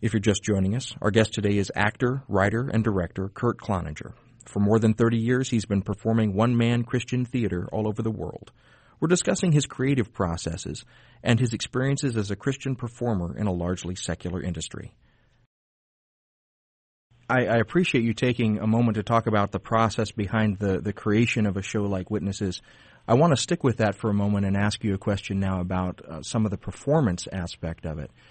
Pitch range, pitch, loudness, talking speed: 100-120 Hz, 110 Hz, -25 LUFS, 195 wpm